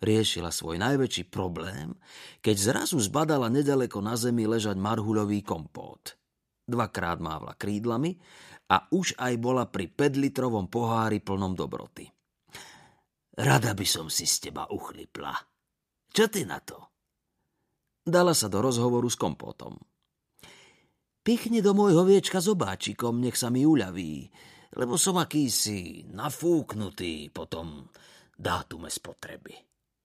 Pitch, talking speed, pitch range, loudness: 120 Hz, 120 wpm, 100-150 Hz, -27 LUFS